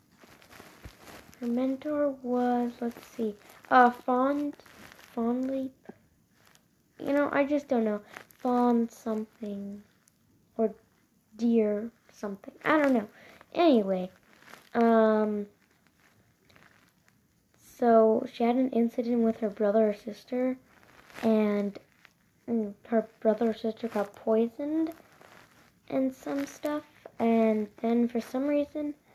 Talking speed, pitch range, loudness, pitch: 100 wpm, 220-265 Hz, -28 LUFS, 235 Hz